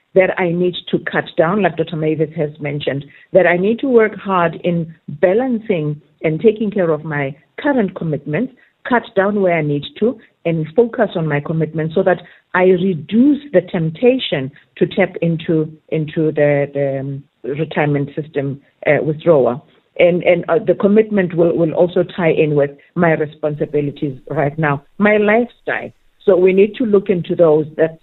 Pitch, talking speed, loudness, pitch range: 170 Hz, 165 wpm, -16 LUFS, 150-195 Hz